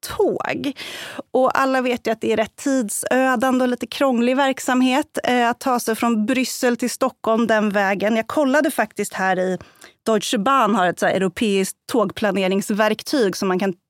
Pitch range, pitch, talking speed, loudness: 210-260 Hz, 235 Hz, 170 wpm, -20 LUFS